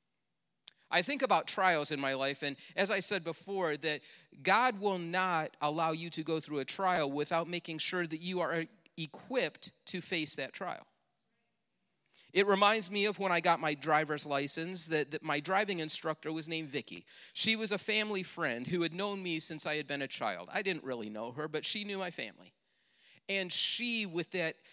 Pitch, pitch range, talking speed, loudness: 165 Hz, 150-195 Hz, 195 wpm, -33 LUFS